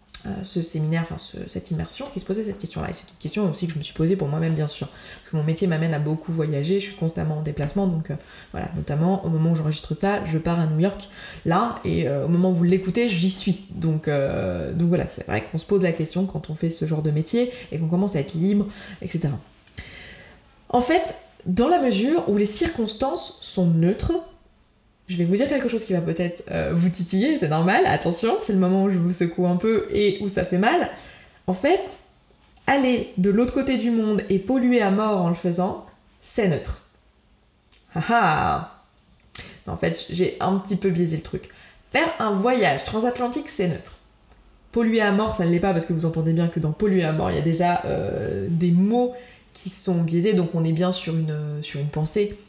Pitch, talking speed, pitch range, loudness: 180 Hz, 225 wpm, 165-205 Hz, -23 LUFS